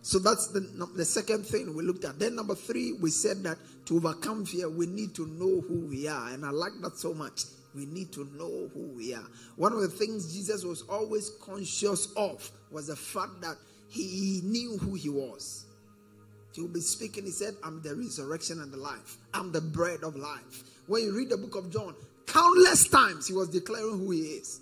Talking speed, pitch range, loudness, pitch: 210 wpm, 155-210 Hz, -30 LUFS, 180 Hz